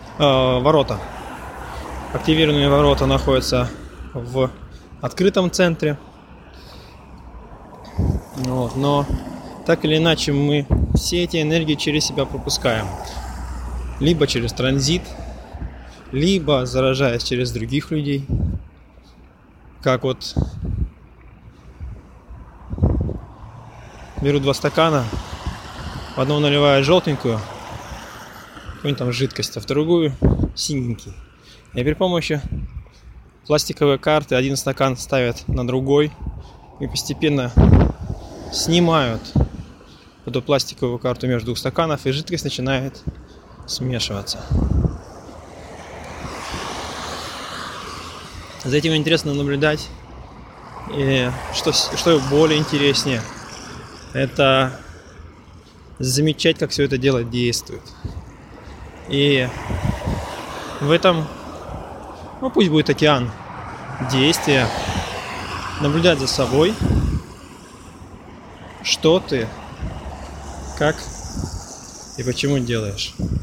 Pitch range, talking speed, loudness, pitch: 100-145 Hz, 80 wpm, -20 LUFS, 130 Hz